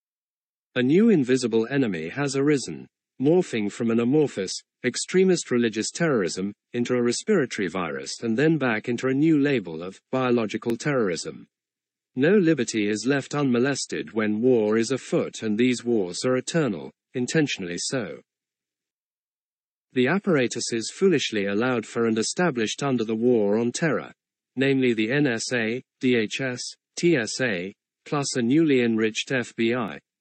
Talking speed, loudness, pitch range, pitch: 130 wpm, -24 LUFS, 115-135 Hz, 125 Hz